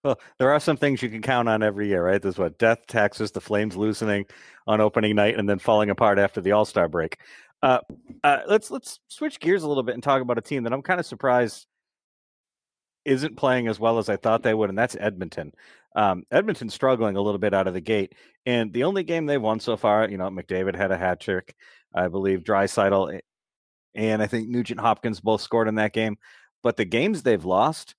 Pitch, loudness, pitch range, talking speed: 110 Hz, -23 LUFS, 105-125 Hz, 225 wpm